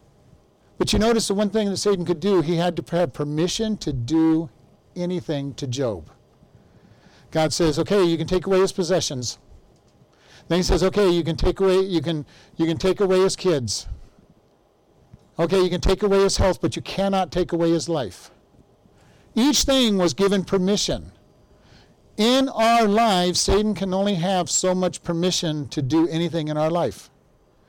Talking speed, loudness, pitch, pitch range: 175 wpm, -21 LUFS, 180 Hz, 165-195 Hz